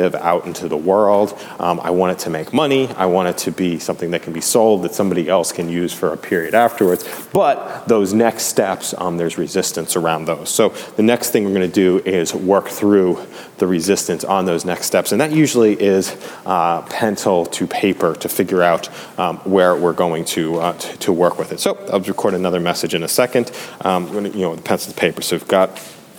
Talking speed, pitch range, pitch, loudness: 220 wpm, 85-100 Hz, 90 Hz, -17 LUFS